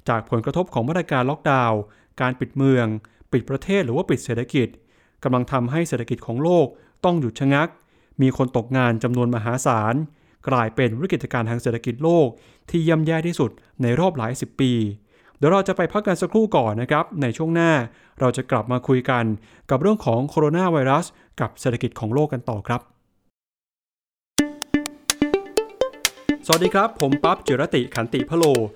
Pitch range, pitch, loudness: 120-165 Hz, 130 Hz, -21 LUFS